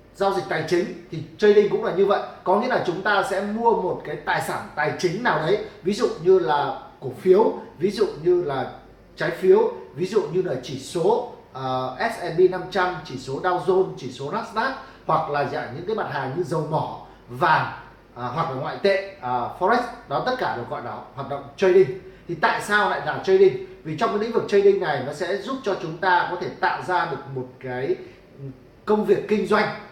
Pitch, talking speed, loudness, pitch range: 185 Hz, 220 wpm, -23 LUFS, 145-210 Hz